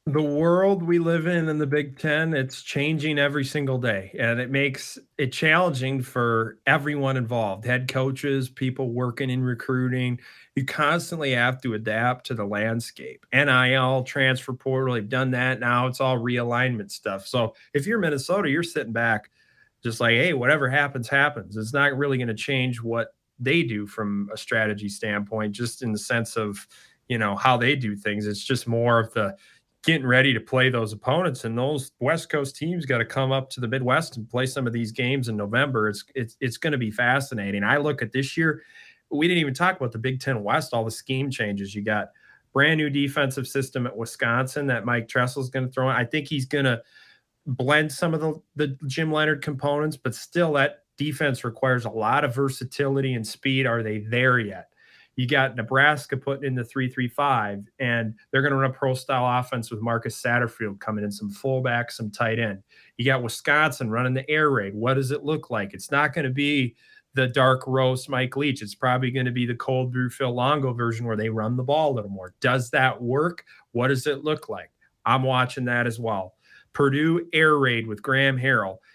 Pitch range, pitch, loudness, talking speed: 115-140 Hz, 130 Hz, -24 LUFS, 205 wpm